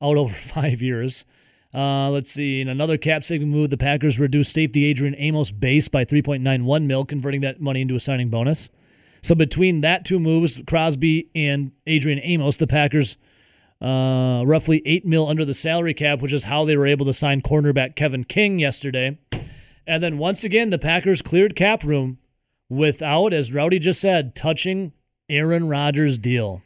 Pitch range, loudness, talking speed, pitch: 135-160 Hz, -20 LUFS, 180 wpm, 145 Hz